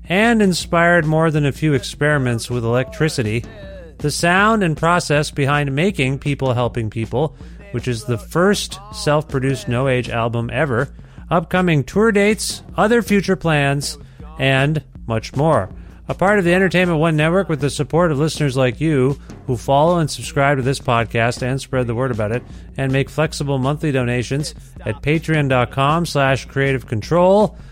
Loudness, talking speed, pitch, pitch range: -18 LUFS, 160 wpm, 140 Hz, 125-165 Hz